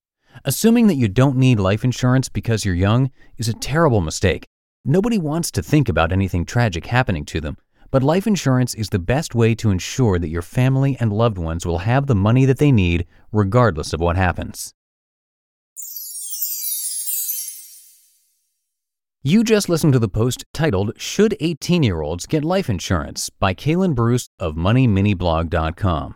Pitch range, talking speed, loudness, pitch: 90-135 Hz, 155 wpm, -19 LUFS, 115 Hz